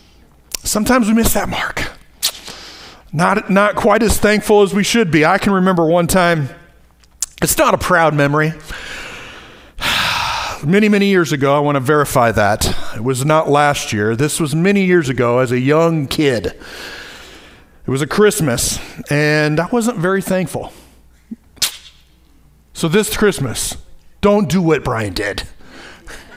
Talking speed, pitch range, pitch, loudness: 145 wpm, 130-200 Hz, 155 Hz, -15 LUFS